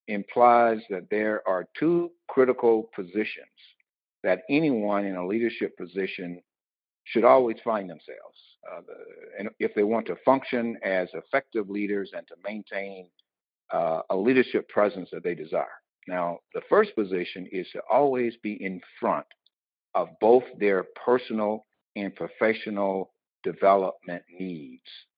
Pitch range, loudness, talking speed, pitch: 95-120 Hz, -26 LUFS, 135 wpm, 105 Hz